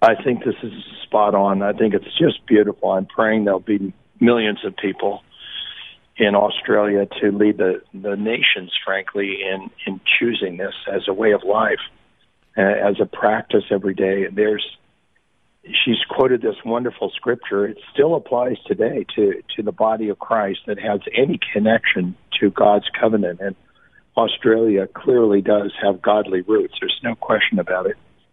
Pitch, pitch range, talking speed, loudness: 105 Hz, 100-110 Hz, 165 wpm, -19 LUFS